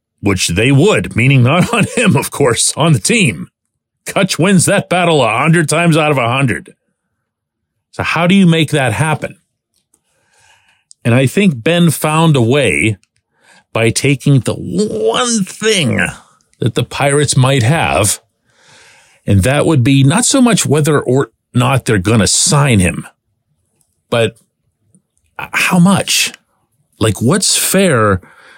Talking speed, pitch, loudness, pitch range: 145 wpm, 145 Hz, -12 LUFS, 125-175 Hz